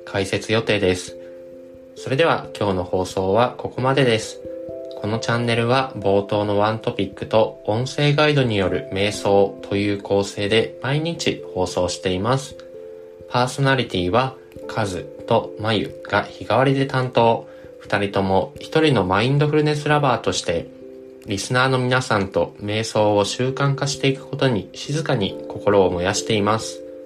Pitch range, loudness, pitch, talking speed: 95-130 Hz, -20 LUFS, 110 Hz, 315 characters per minute